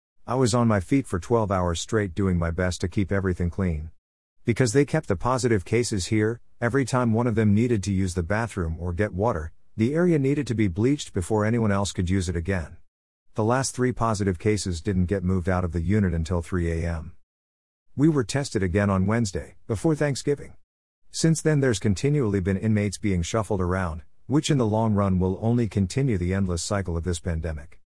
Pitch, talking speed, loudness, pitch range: 100 Hz, 205 wpm, -25 LUFS, 90-115 Hz